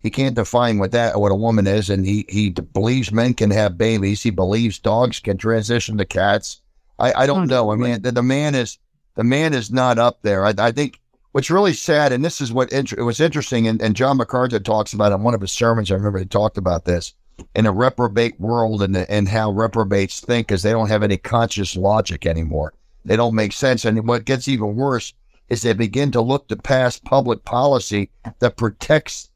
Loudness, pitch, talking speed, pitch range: -19 LUFS, 115 Hz, 220 wpm, 105-125 Hz